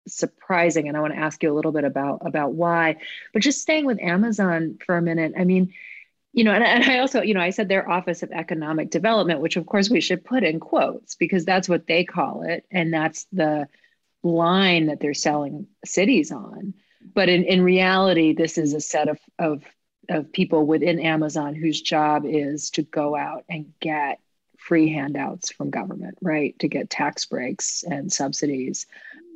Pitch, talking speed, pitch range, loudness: 170 Hz, 190 wpm, 155-190 Hz, -22 LUFS